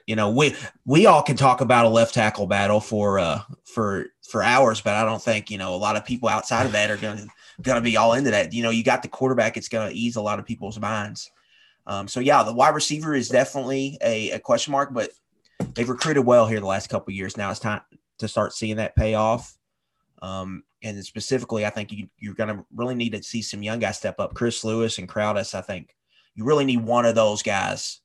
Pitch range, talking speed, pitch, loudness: 105-120 Hz, 245 wpm, 110 Hz, -22 LUFS